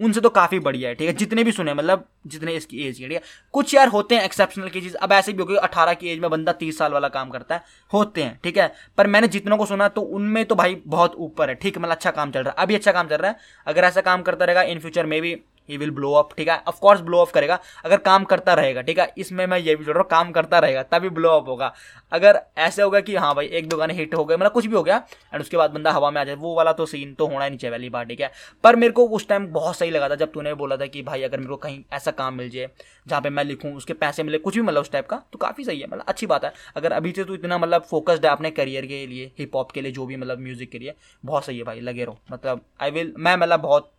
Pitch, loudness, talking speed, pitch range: 165 Hz, -21 LUFS, 310 wpm, 140-185 Hz